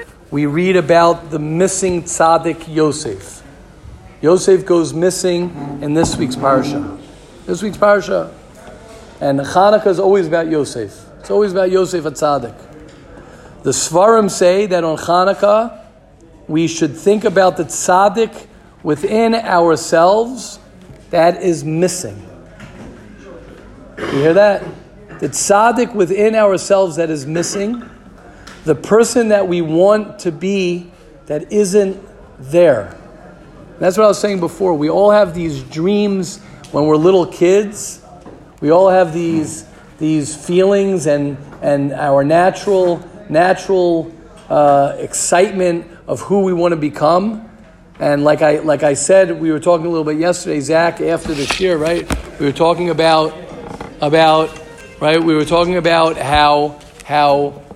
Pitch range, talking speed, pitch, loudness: 155-190 Hz, 135 wpm, 170 Hz, -14 LUFS